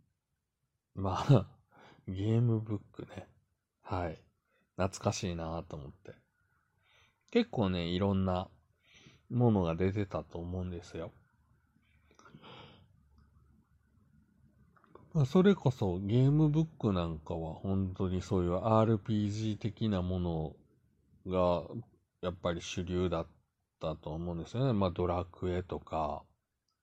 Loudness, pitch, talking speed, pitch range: -33 LUFS, 95 Hz, 210 characters per minute, 85-110 Hz